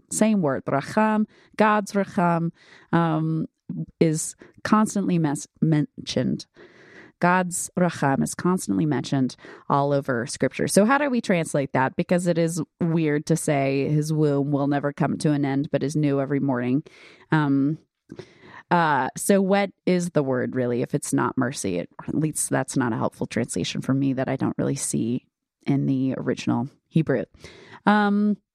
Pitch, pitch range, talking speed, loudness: 155 Hz, 140-180 Hz, 160 wpm, -23 LUFS